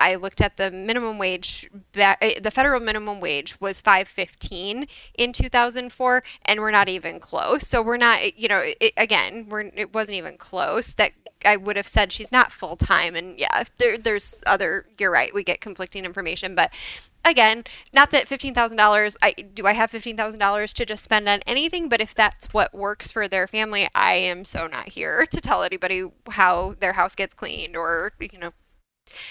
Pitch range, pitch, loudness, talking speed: 195-235 Hz, 210 Hz, -20 LUFS, 185 wpm